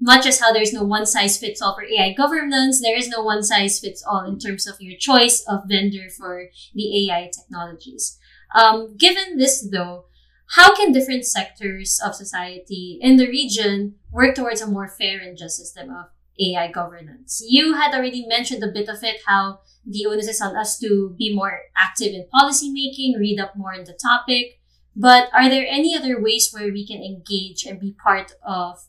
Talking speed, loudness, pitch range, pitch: 195 wpm, -18 LUFS, 190-245 Hz, 210 Hz